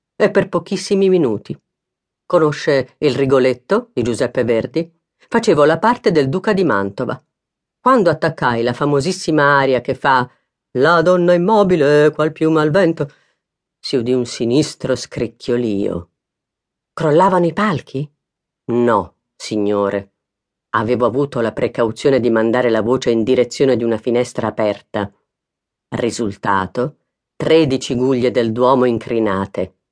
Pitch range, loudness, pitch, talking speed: 120-160 Hz, -16 LUFS, 130 Hz, 120 wpm